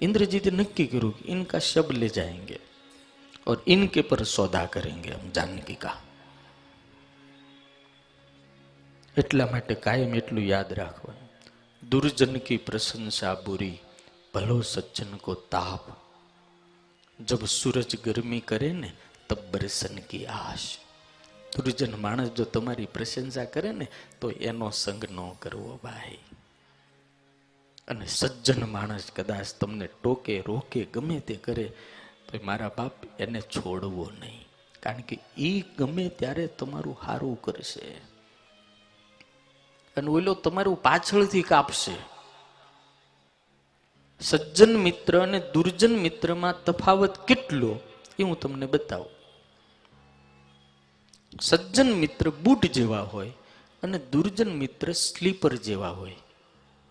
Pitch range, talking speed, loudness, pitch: 100-160 Hz, 105 wpm, -27 LUFS, 120 Hz